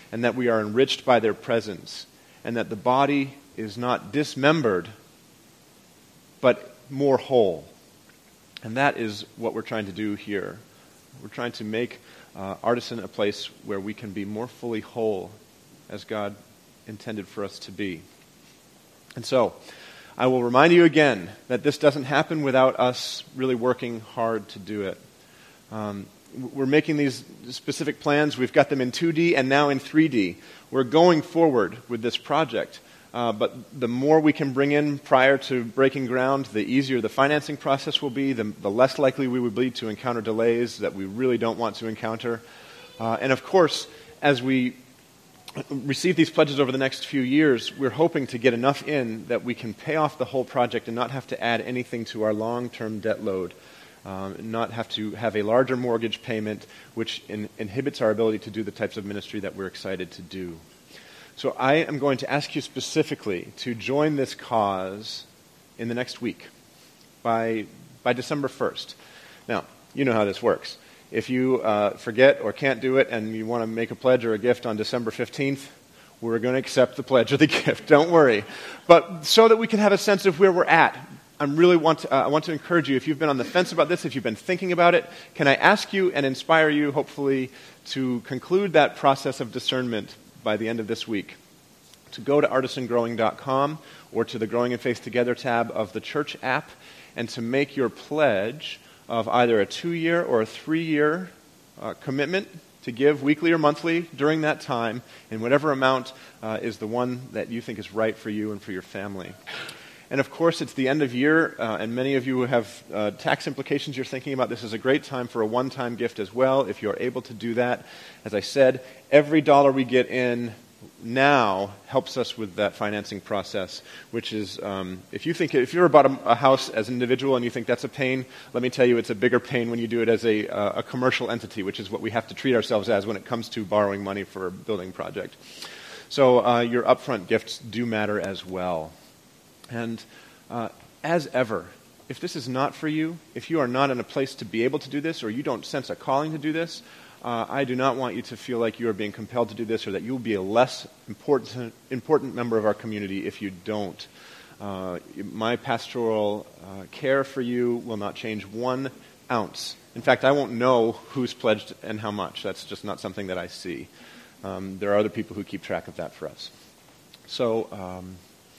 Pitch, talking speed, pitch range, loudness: 125 Hz, 210 wpm, 110-140 Hz, -24 LUFS